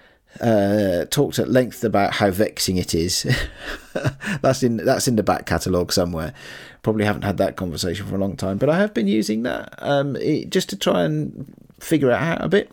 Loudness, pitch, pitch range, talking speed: -21 LUFS, 110 Hz, 95-140 Hz, 205 wpm